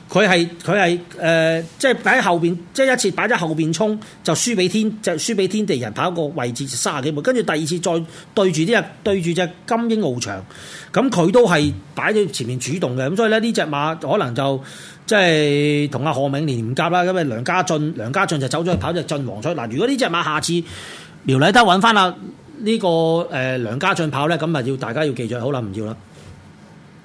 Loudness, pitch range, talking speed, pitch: -19 LUFS, 145-195 Hz, 305 characters per minute, 170 Hz